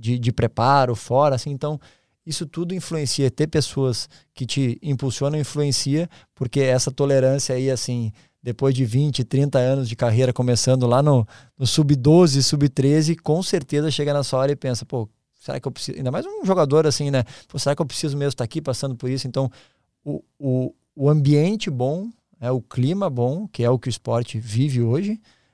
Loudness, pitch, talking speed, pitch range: -21 LUFS, 135 Hz, 195 wpm, 125-150 Hz